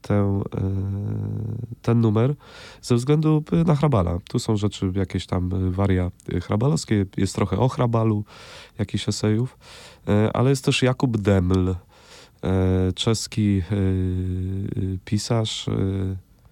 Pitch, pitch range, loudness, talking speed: 105 Hz, 95-120 Hz, -23 LUFS, 100 wpm